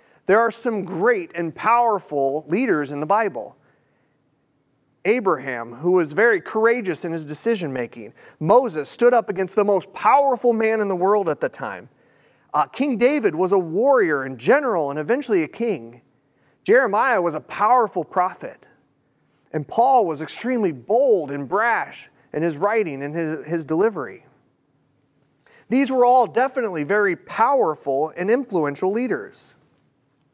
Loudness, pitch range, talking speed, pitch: -20 LUFS, 150-235 Hz, 145 wpm, 190 Hz